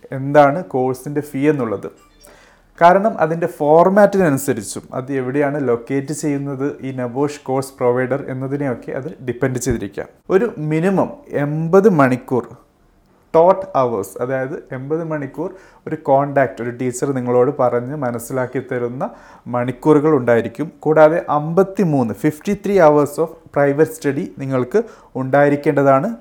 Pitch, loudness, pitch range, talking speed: 140 Hz, -17 LUFS, 130-155 Hz, 110 wpm